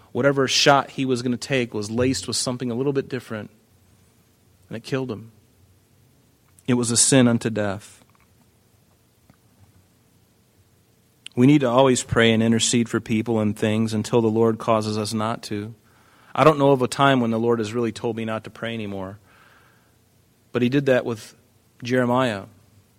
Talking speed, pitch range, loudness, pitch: 170 wpm, 110-125 Hz, -21 LUFS, 115 Hz